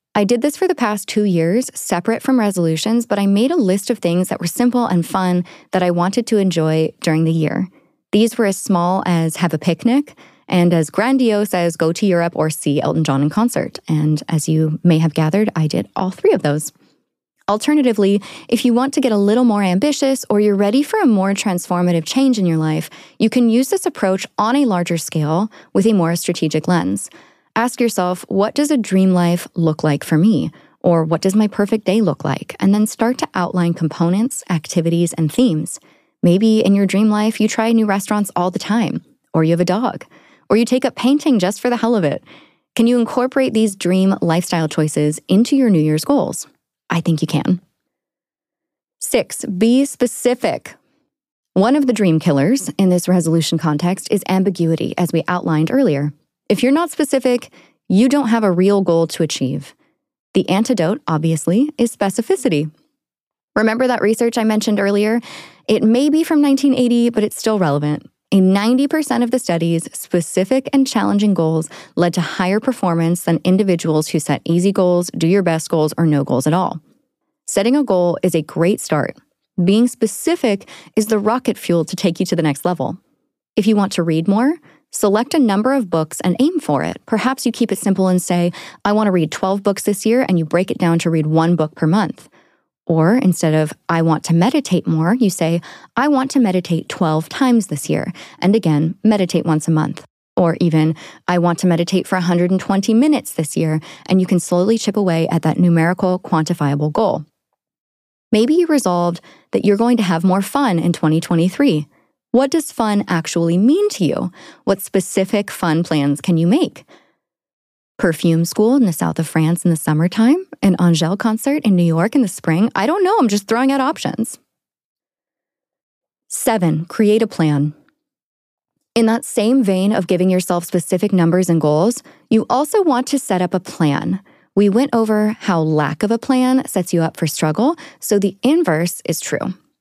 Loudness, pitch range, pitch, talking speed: -16 LUFS, 170-235 Hz, 190 Hz, 195 wpm